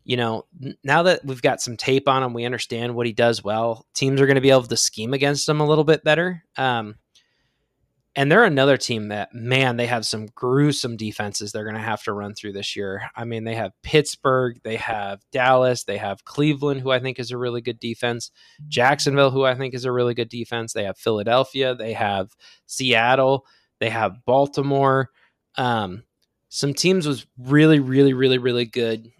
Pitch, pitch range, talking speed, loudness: 125 Hz, 115-140 Hz, 200 wpm, -21 LUFS